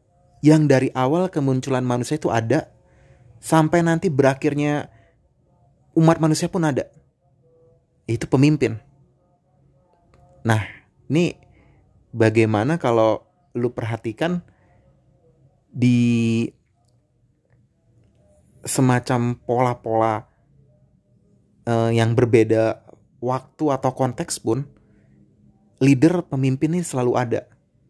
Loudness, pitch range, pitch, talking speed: -20 LUFS, 115-145 Hz, 130 Hz, 75 wpm